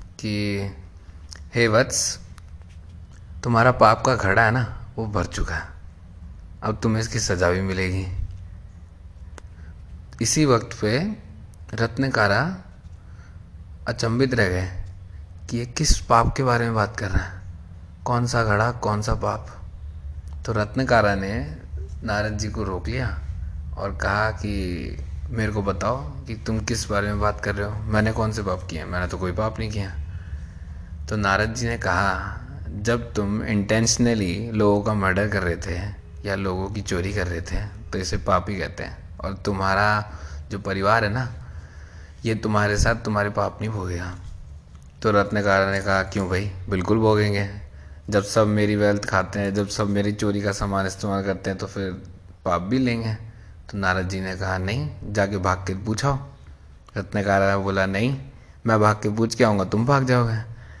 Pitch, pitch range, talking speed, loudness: 100 Hz, 90-110 Hz, 165 wpm, -23 LUFS